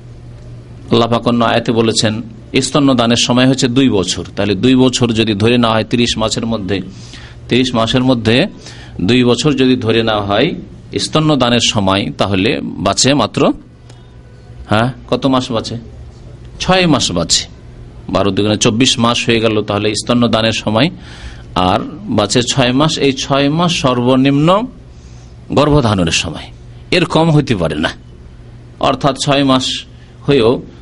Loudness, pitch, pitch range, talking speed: -13 LUFS, 120 Hz, 105-130 Hz, 135 wpm